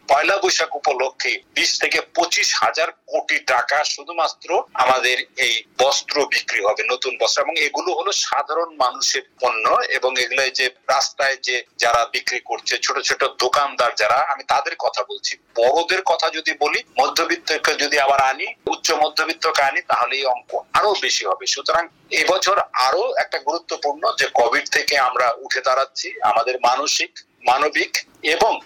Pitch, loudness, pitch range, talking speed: 160 Hz, -19 LUFS, 140-185 Hz, 150 wpm